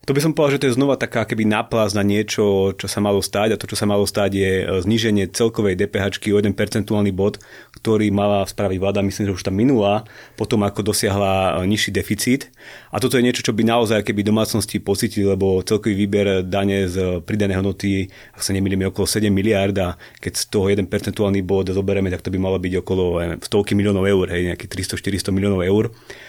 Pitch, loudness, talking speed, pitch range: 100 Hz, -19 LUFS, 210 wpm, 95-110 Hz